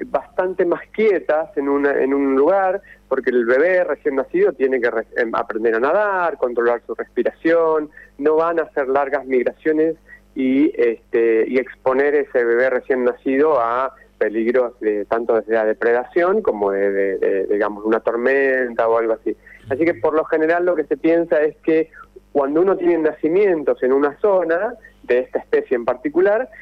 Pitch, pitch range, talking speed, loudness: 145 Hz, 125-175 Hz, 175 wpm, -18 LUFS